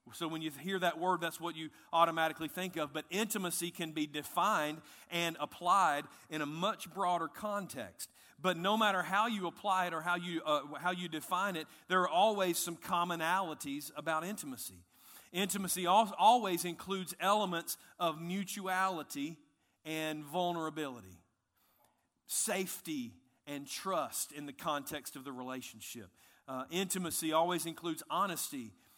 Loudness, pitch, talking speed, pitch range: -35 LUFS, 170 Hz, 140 wpm, 150-185 Hz